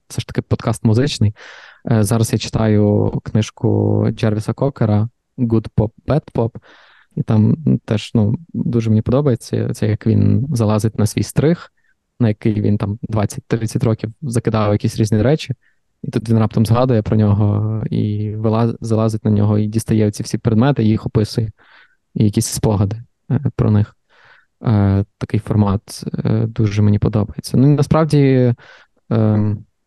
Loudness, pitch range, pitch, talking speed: -17 LUFS, 105-120 Hz, 110 Hz, 145 wpm